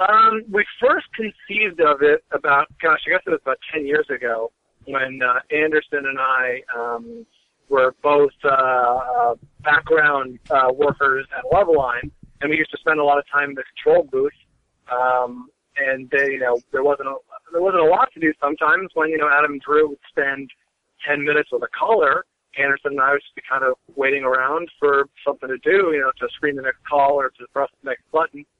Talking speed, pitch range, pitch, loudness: 210 wpm, 130-185 Hz, 145 Hz, -19 LUFS